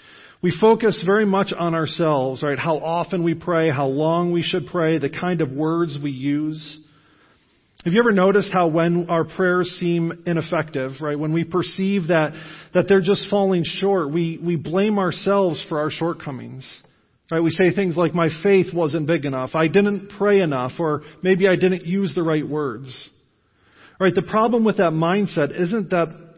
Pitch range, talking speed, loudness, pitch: 155-190 Hz, 180 wpm, -20 LUFS, 170 Hz